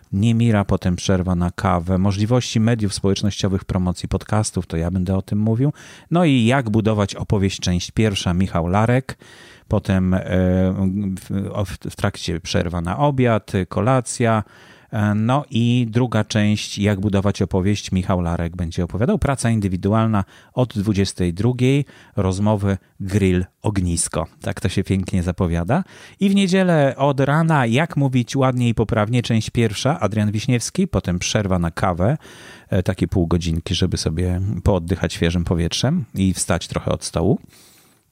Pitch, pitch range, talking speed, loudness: 100 Hz, 95-115 Hz, 135 wpm, -20 LUFS